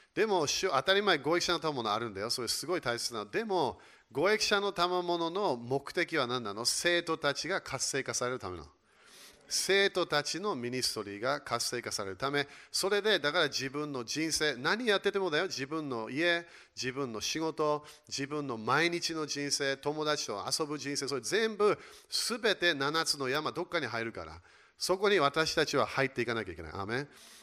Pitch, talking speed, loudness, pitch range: 150 Hz, 355 characters per minute, -31 LUFS, 130-175 Hz